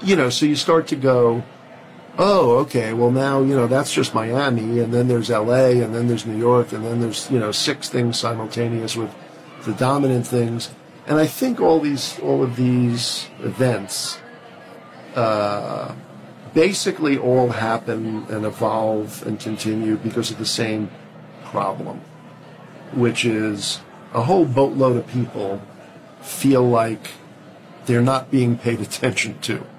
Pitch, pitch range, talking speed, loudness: 120 Hz, 110-130 Hz, 150 wpm, -20 LUFS